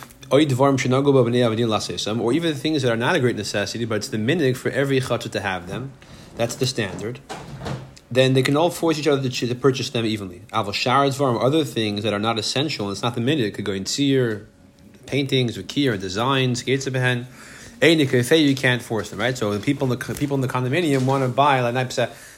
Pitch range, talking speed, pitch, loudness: 110-135 Hz, 200 wpm, 125 Hz, -21 LUFS